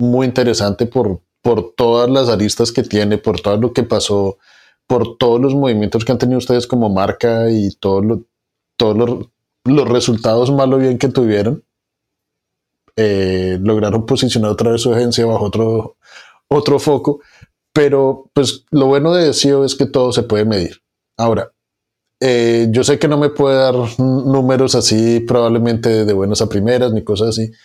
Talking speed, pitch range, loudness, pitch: 170 wpm, 110-130 Hz, -14 LUFS, 120 Hz